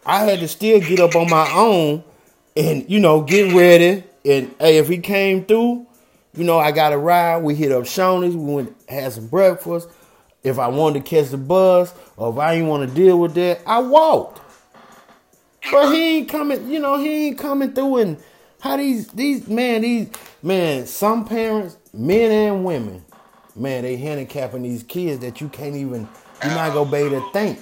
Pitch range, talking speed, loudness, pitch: 150-220 Hz, 200 wpm, -17 LUFS, 175 Hz